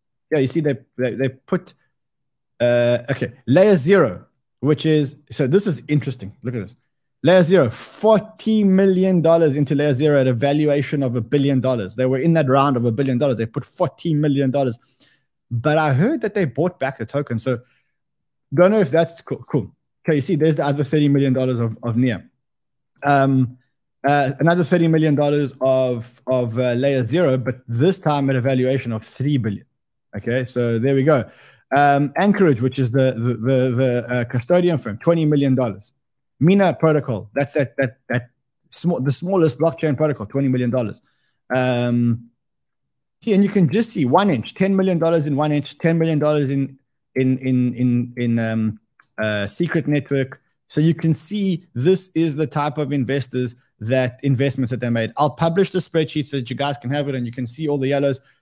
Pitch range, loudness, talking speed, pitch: 125-155 Hz, -19 LUFS, 190 wpm, 140 Hz